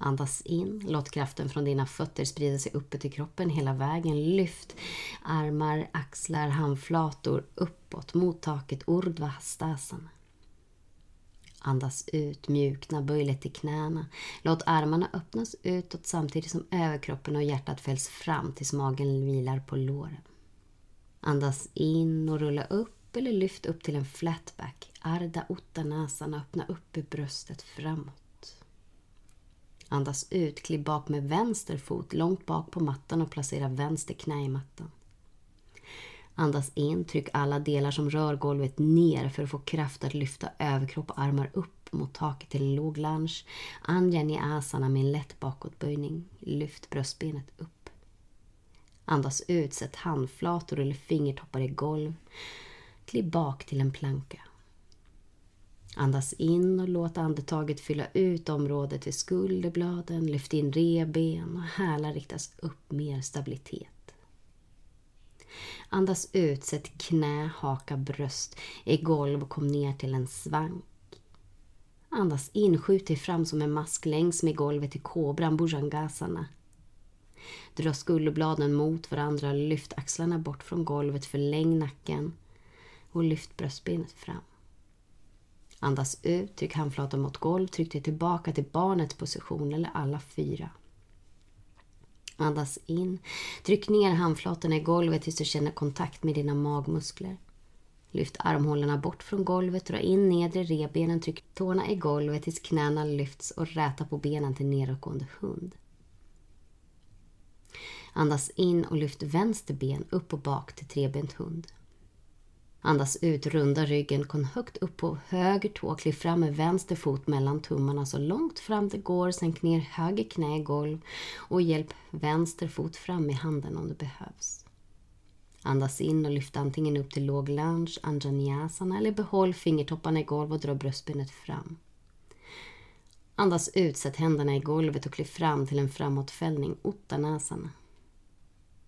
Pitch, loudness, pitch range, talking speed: 150 Hz, -31 LUFS, 140-165 Hz, 140 wpm